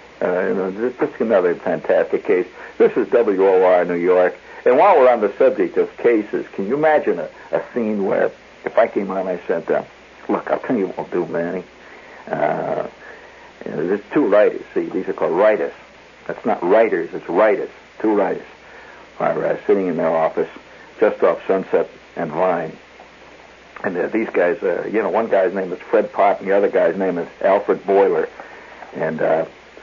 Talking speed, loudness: 195 wpm, -19 LUFS